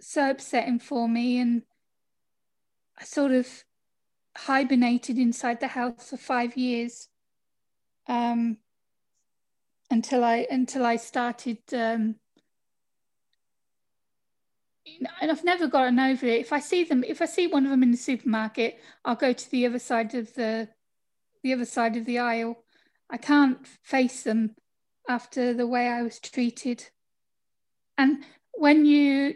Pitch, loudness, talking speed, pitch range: 245 Hz, -26 LUFS, 140 wpm, 235-270 Hz